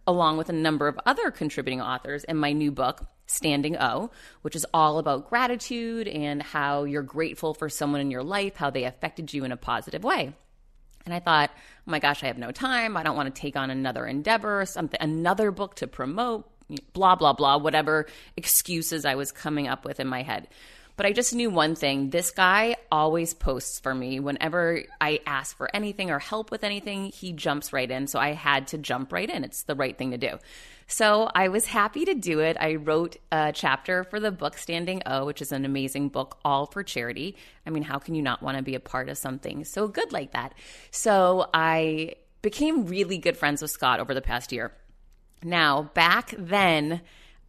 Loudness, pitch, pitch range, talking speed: -26 LUFS, 155 Hz, 140-185 Hz, 210 wpm